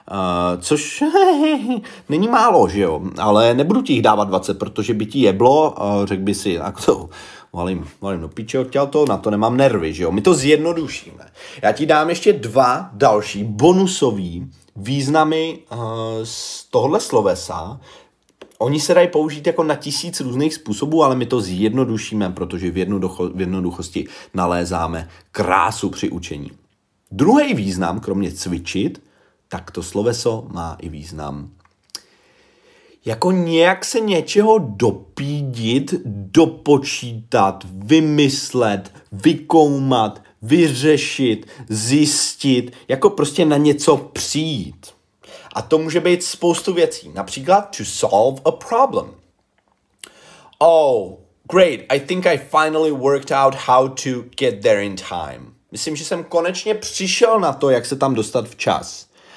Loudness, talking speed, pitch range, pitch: -17 LUFS, 135 wpm, 100-160 Hz, 135 Hz